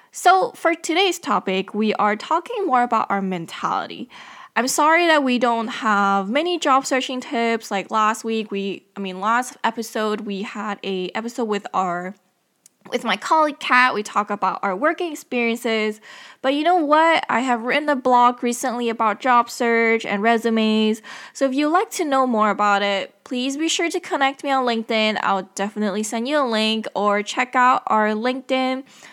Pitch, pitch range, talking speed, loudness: 235 Hz, 210-275 Hz, 180 wpm, -20 LUFS